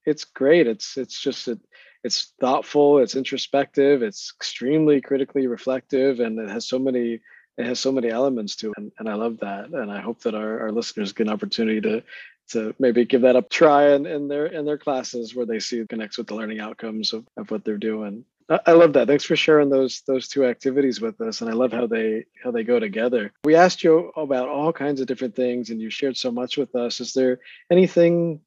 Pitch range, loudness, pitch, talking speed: 115-145 Hz, -22 LUFS, 130 Hz, 230 wpm